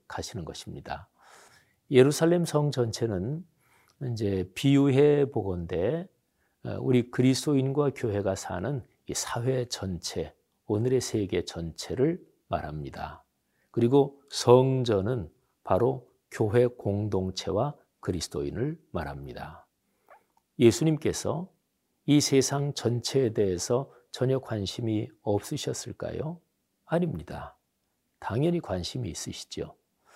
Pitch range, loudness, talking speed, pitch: 105-145 Hz, -28 LUFS, 230 characters per minute, 125 Hz